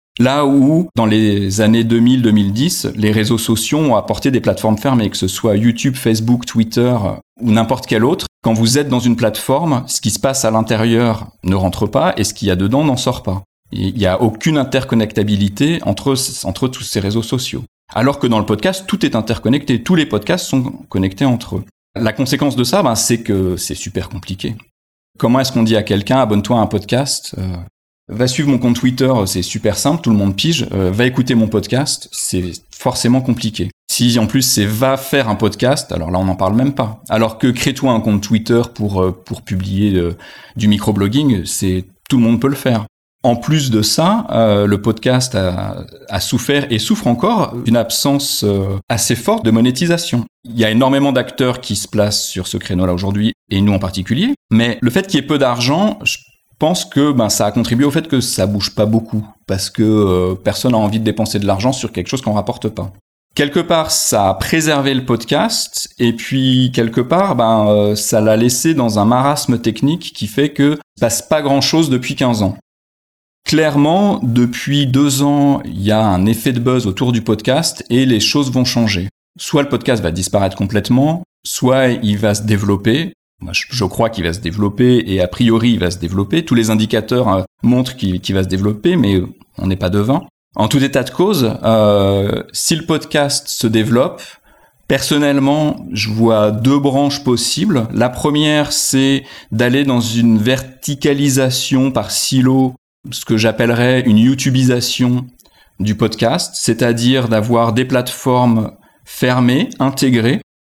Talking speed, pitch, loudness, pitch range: 190 wpm, 120 Hz, -15 LUFS, 105-135 Hz